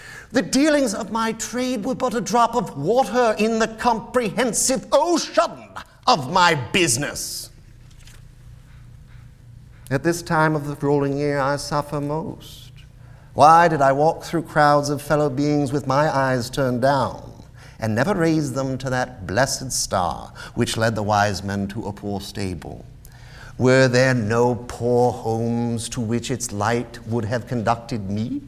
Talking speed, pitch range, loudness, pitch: 150 wpm, 120-160 Hz, -21 LUFS, 130 Hz